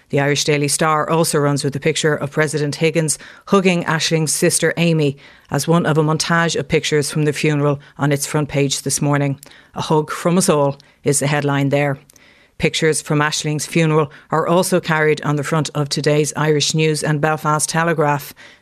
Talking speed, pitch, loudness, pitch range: 185 wpm, 150 Hz, -17 LUFS, 145-160 Hz